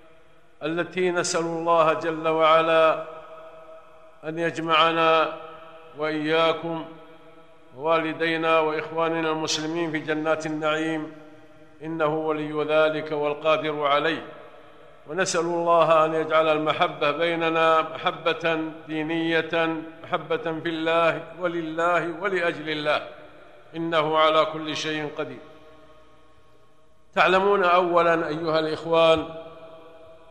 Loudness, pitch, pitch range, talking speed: -23 LUFS, 160 Hz, 155-165 Hz, 85 wpm